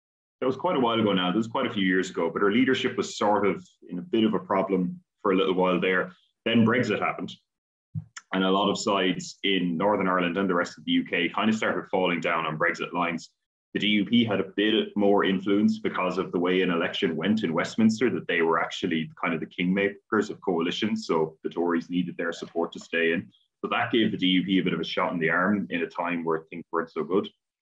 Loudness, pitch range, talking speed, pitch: -26 LUFS, 90-105 Hz, 245 wpm, 95 Hz